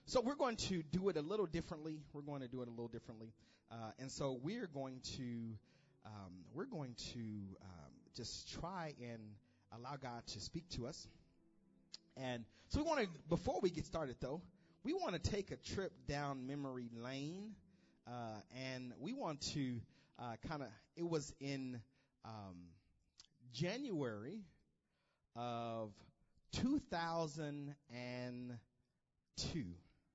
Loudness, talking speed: -46 LUFS, 145 wpm